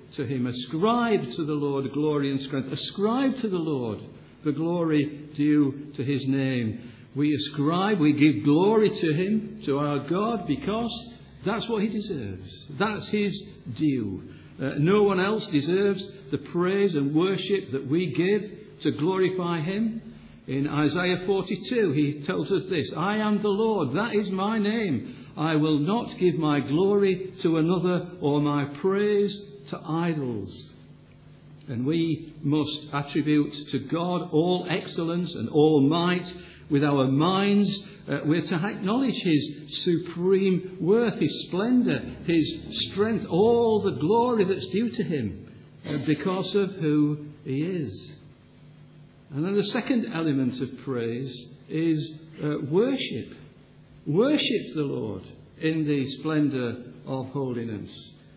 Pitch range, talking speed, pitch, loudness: 145-195 Hz, 140 wpm, 160 Hz, -26 LUFS